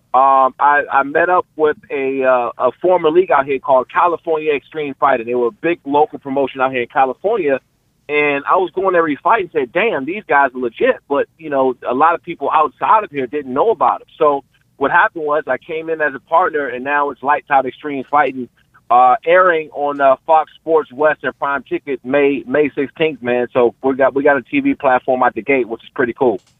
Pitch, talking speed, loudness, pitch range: 145 Hz, 225 wpm, -16 LUFS, 135-160 Hz